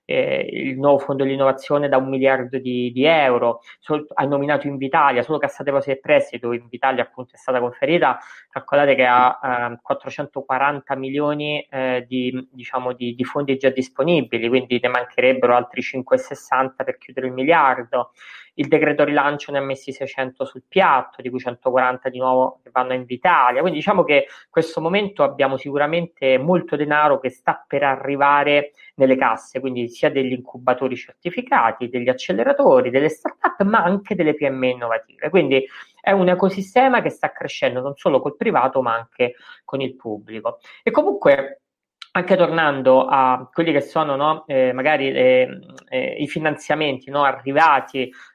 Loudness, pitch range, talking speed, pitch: -19 LUFS, 130-150 Hz, 160 wpm, 135 Hz